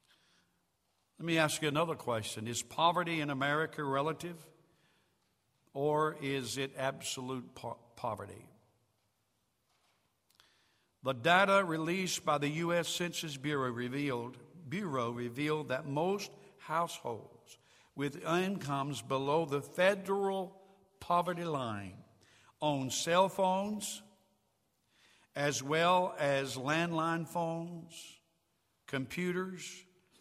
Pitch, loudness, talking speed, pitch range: 155 Hz, -34 LUFS, 95 wpm, 135-175 Hz